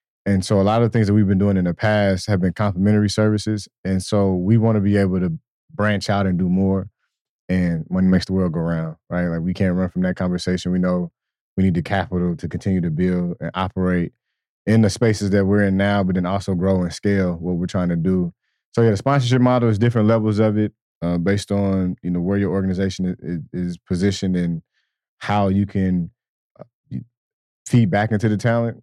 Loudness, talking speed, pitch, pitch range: -20 LUFS, 220 wpm, 95 Hz, 90-105 Hz